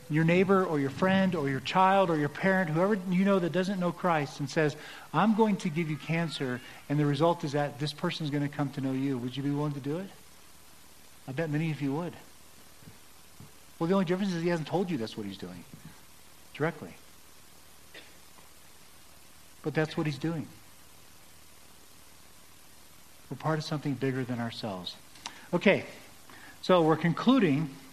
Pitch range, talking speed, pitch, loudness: 110-170 Hz, 180 wpm, 145 Hz, -29 LUFS